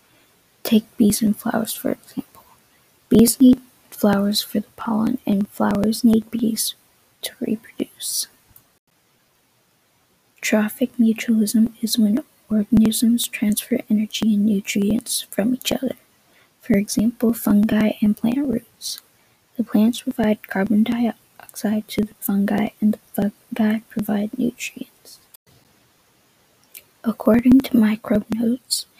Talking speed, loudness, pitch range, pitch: 110 wpm, -20 LUFS, 215-235 Hz, 225 Hz